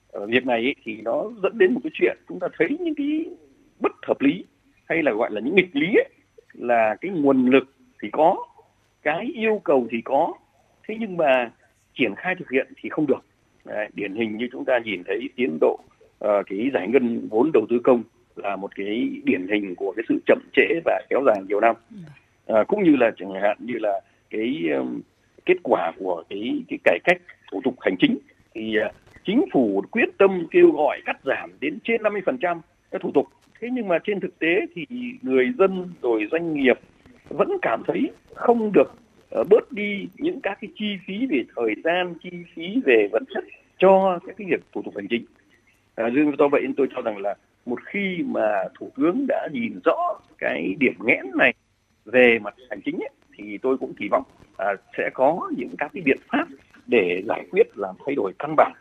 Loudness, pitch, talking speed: -23 LUFS, 205 Hz, 205 wpm